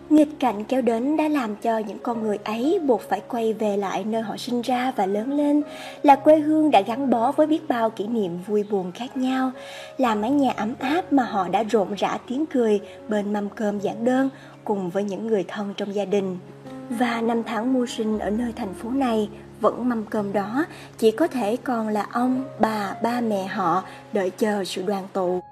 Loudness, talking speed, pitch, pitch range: -23 LUFS, 215 wpm, 225 Hz, 205-260 Hz